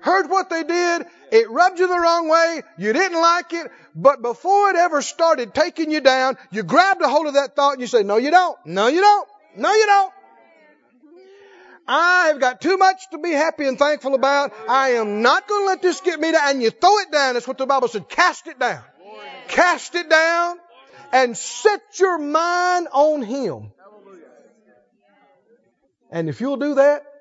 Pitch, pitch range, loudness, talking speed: 315 Hz, 265-355 Hz, -18 LUFS, 195 wpm